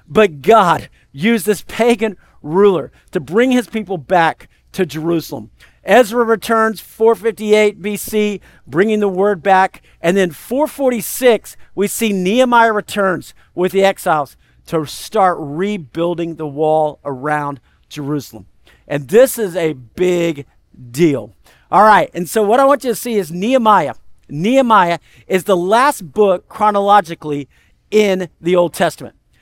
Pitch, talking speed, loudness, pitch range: 190 Hz, 135 wpm, -15 LUFS, 155-215 Hz